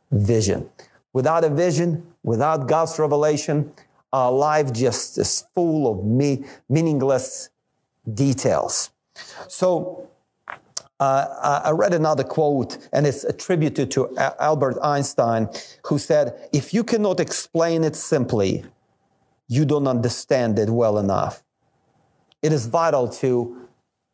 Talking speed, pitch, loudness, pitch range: 115 wpm, 145 Hz, -21 LUFS, 125-155 Hz